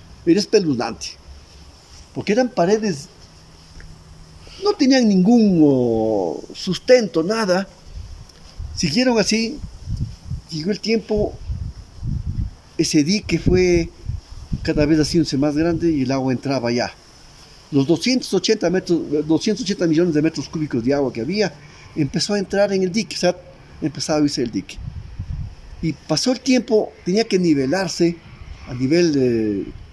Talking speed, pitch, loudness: 125 wpm, 155 Hz, -19 LUFS